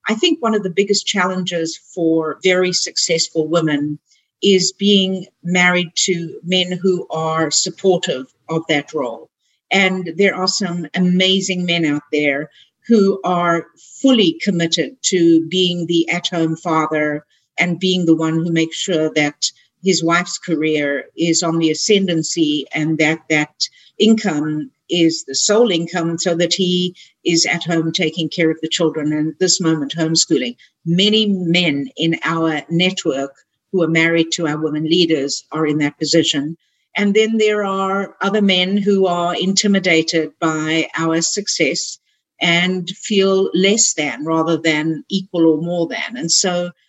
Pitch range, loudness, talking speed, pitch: 160-185 Hz, -16 LUFS, 150 wpm, 170 Hz